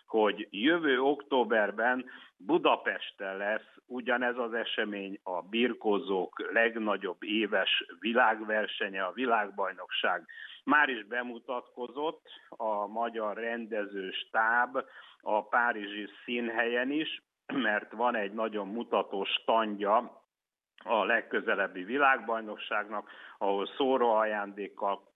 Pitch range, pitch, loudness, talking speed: 105-120 Hz, 115 Hz, -31 LUFS, 90 wpm